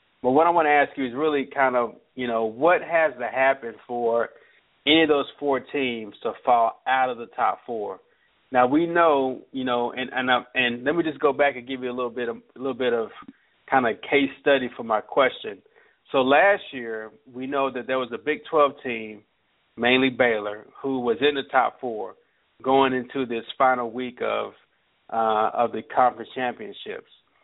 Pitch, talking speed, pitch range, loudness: 130 Hz, 205 wpm, 120-140 Hz, -23 LUFS